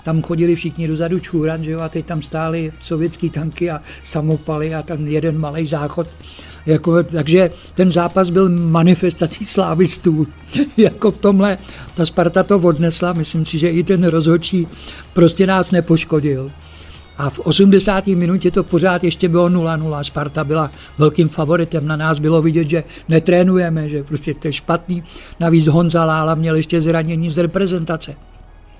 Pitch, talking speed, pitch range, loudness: 165 Hz, 155 wpm, 155-175 Hz, -16 LUFS